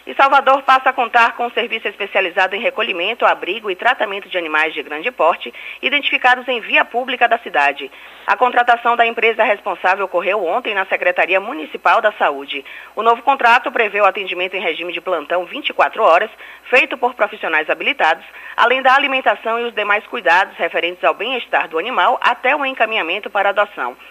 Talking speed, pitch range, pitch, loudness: 175 wpm, 190-245 Hz, 220 Hz, -16 LUFS